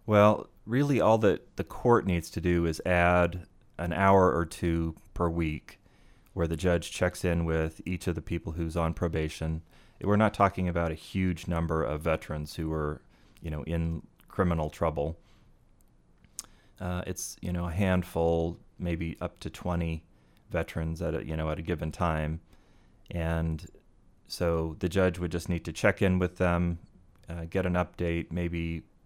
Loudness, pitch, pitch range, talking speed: -29 LUFS, 85 Hz, 80-90 Hz, 170 wpm